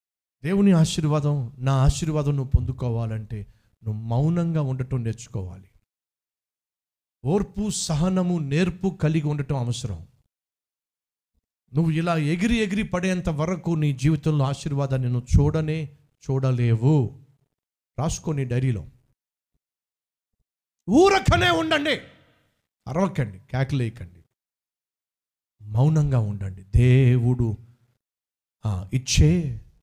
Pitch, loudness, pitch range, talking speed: 135 Hz, -23 LUFS, 120-160 Hz, 75 wpm